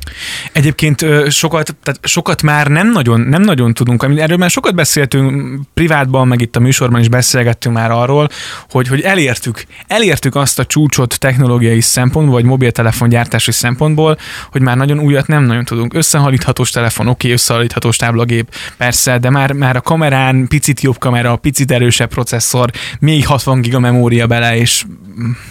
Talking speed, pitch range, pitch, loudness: 155 wpm, 120-145 Hz, 130 Hz, -11 LUFS